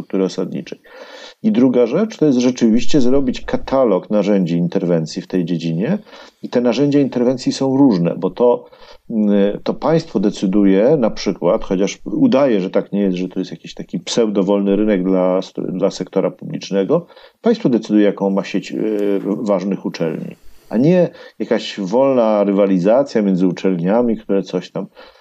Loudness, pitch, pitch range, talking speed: -17 LUFS, 100 Hz, 95-125 Hz, 150 wpm